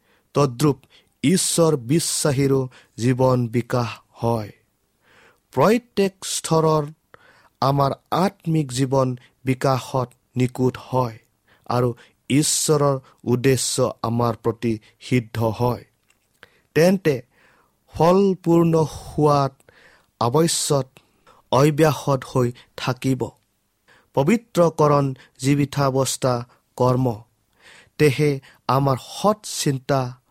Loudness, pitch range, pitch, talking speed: -21 LUFS, 120-150 Hz, 135 Hz, 70 wpm